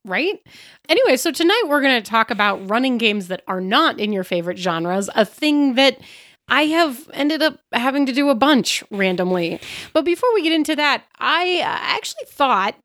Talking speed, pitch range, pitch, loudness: 185 wpm, 205-320 Hz, 275 Hz, -18 LUFS